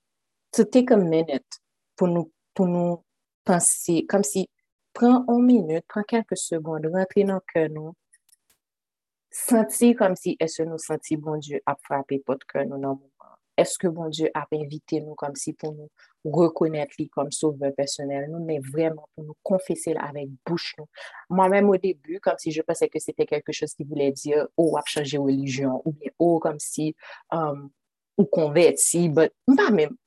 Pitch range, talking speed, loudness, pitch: 150-185 Hz, 180 wpm, -24 LUFS, 160 Hz